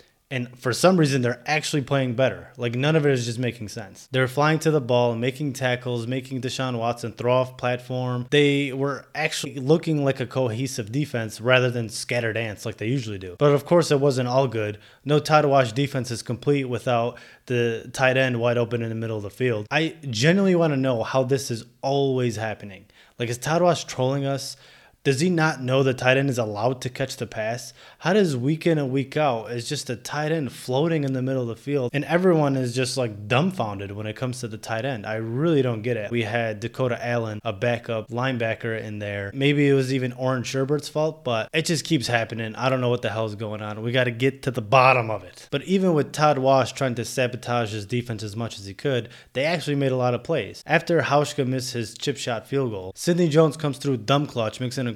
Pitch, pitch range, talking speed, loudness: 130 Hz, 120-140 Hz, 230 wpm, -24 LUFS